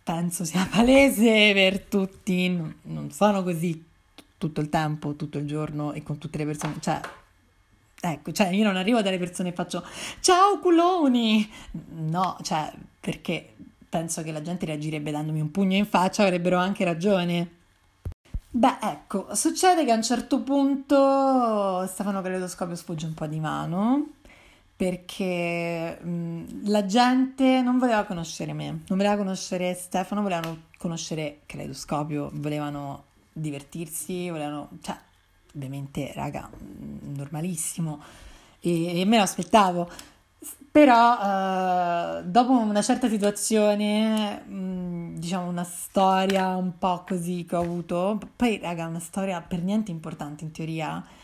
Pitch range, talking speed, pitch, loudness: 160-205 Hz, 135 wpm, 180 Hz, -25 LUFS